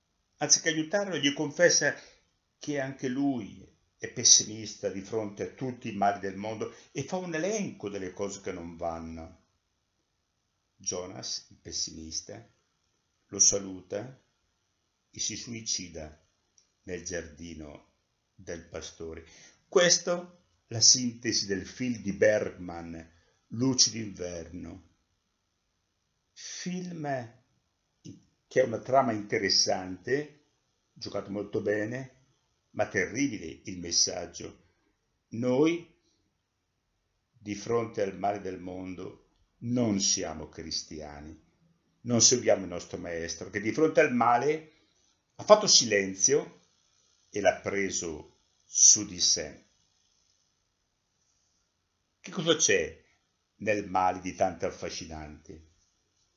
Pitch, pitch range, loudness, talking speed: 100 Hz, 90-125 Hz, -27 LUFS, 105 wpm